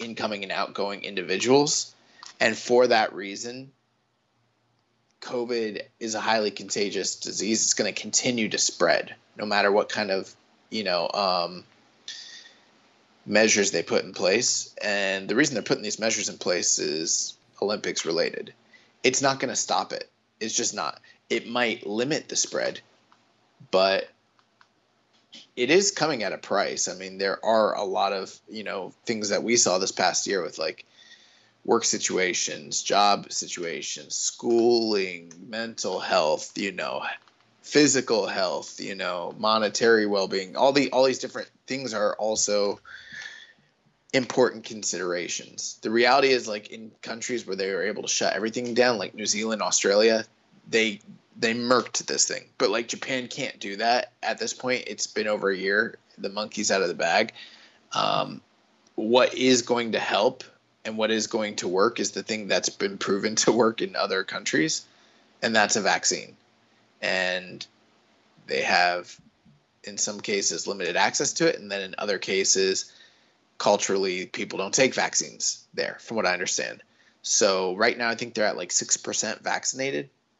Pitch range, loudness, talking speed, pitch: 100-120 Hz, -25 LUFS, 160 wpm, 110 Hz